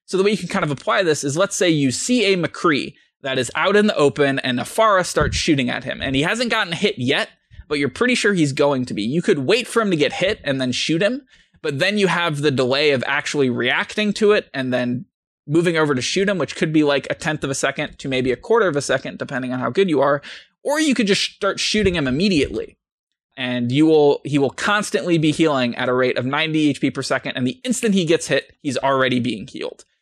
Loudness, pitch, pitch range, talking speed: -19 LUFS, 155 Hz, 135-200 Hz, 255 wpm